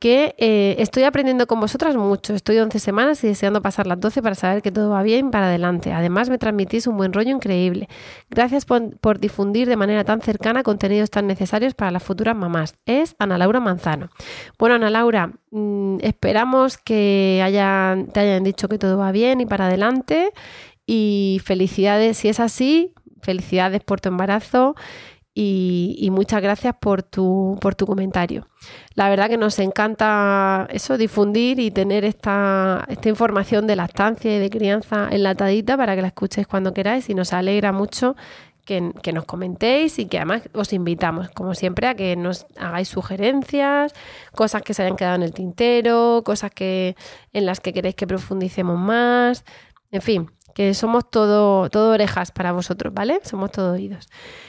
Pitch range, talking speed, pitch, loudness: 190-225 Hz, 175 wpm, 205 Hz, -19 LUFS